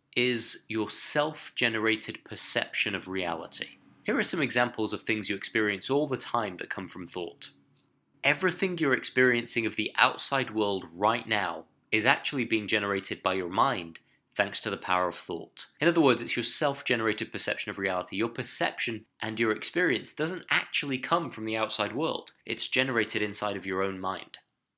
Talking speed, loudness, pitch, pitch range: 175 wpm, -28 LUFS, 110 Hz, 100-125 Hz